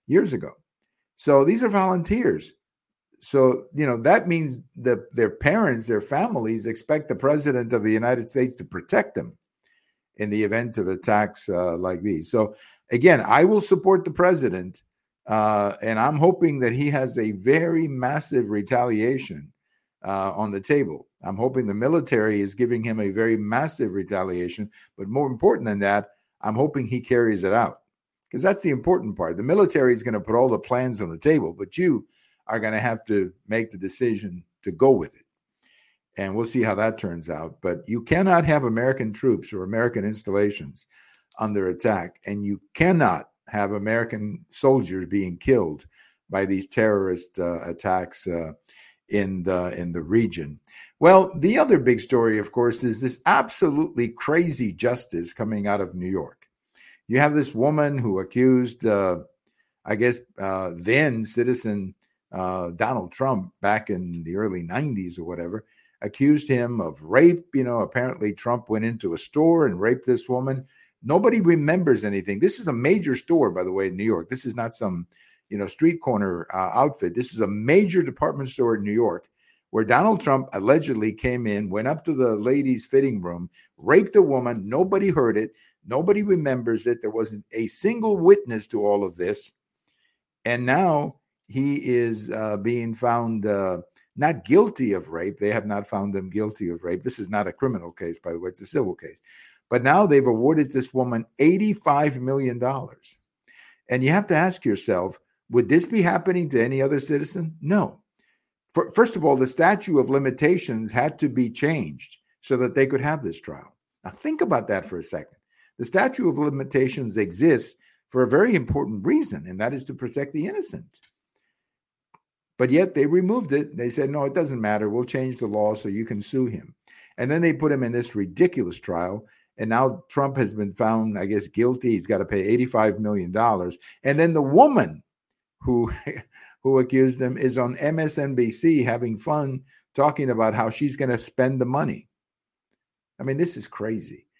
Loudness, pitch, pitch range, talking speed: -23 LUFS, 120 Hz, 105-140 Hz, 180 wpm